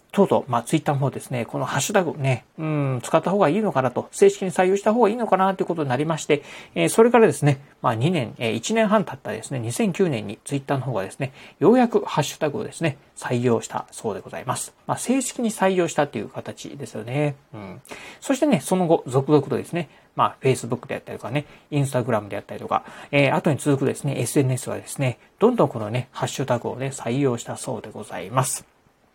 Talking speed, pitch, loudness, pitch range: 480 characters per minute, 145 Hz, -23 LUFS, 130-185 Hz